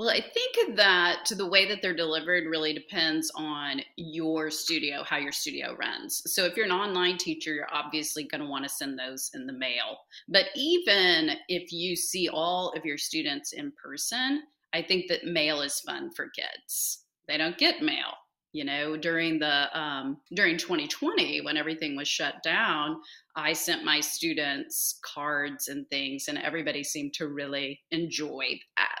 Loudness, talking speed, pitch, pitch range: -28 LUFS, 175 wpm, 160 Hz, 150-210 Hz